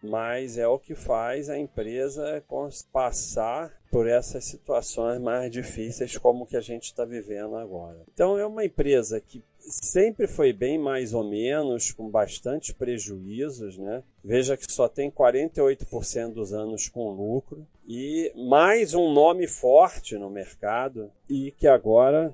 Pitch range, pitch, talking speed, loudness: 110-140 Hz, 120 Hz, 145 wpm, -25 LUFS